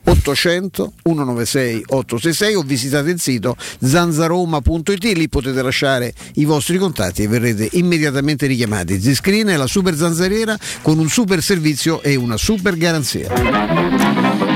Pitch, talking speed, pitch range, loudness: 150 Hz, 120 wpm, 125-175 Hz, -16 LUFS